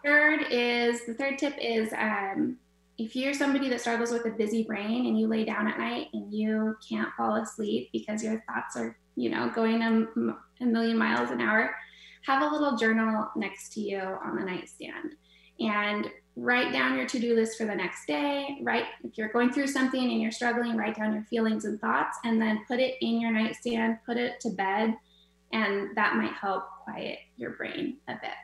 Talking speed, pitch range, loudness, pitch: 200 wpm, 210-245 Hz, -29 LUFS, 225 Hz